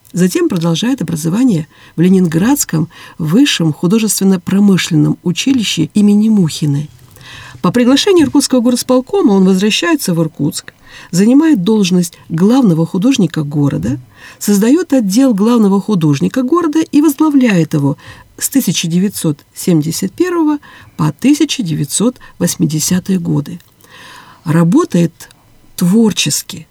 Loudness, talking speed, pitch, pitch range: -12 LUFS, 85 wpm, 185 Hz, 160-245 Hz